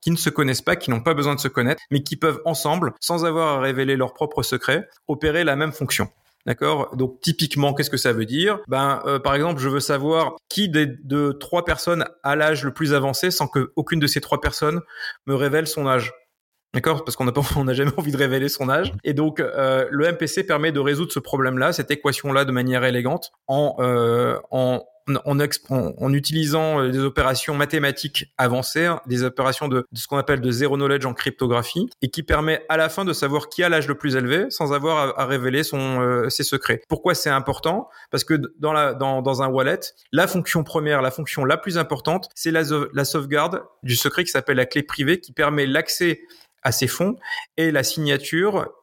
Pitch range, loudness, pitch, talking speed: 135-160 Hz, -21 LUFS, 145 Hz, 215 wpm